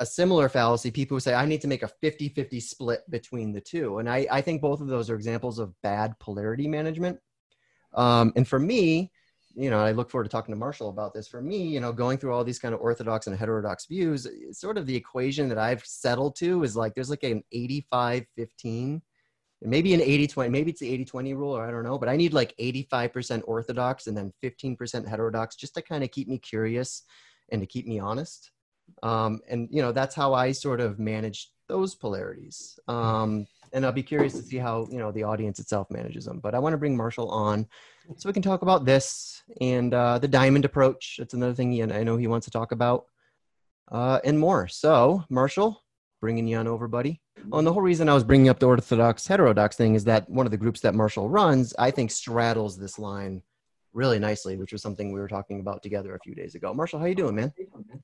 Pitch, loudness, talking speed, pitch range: 125 Hz, -26 LUFS, 230 wpm, 110-140 Hz